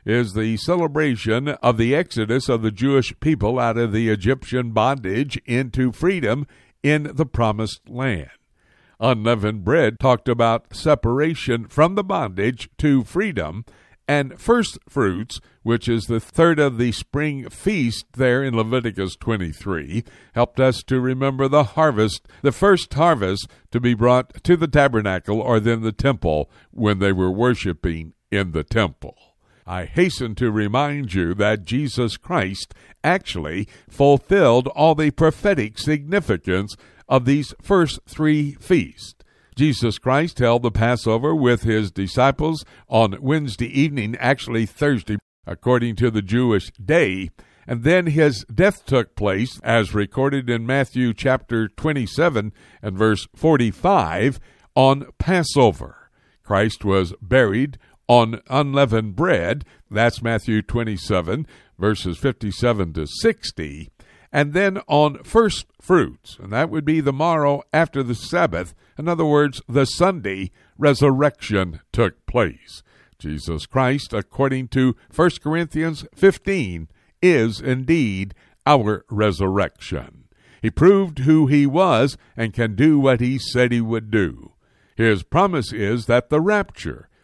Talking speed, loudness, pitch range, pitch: 130 wpm, -20 LUFS, 105-145 Hz, 120 Hz